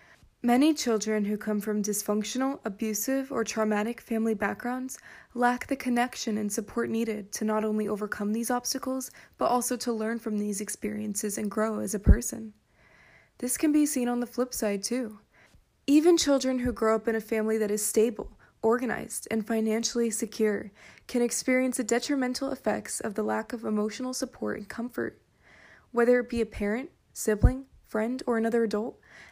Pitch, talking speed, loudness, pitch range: 225 Hz, 170 wpm, -28 LUFS, 215-250 Hz